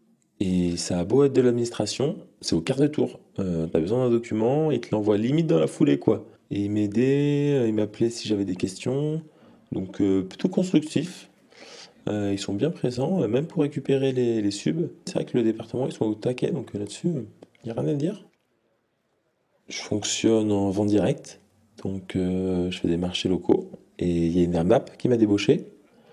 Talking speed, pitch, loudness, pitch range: 200 wpm, 110 Hz, -25 LUFS, 100-135 Hz